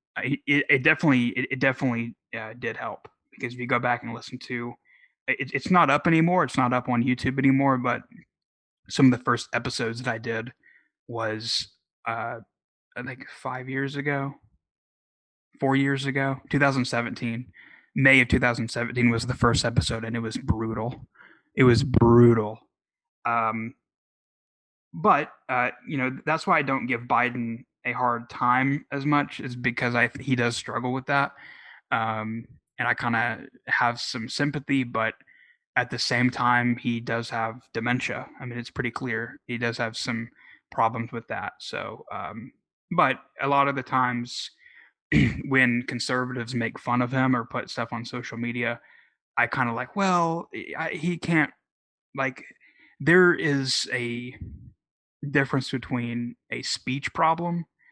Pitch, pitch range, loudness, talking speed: 125 Hz, 115-135 Hz, -25 LUFS, 155 wpm